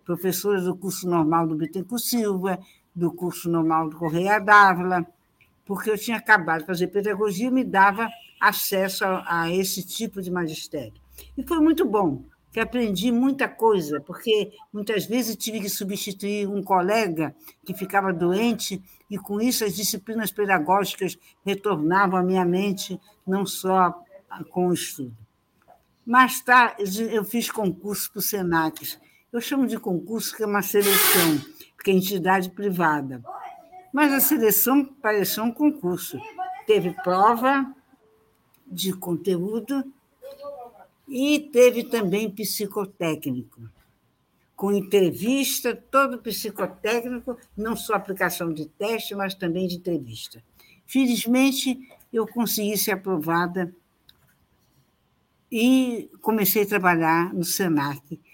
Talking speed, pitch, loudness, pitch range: 125 wpm, 200 Hz, -23 LUFS, 180-230 Hz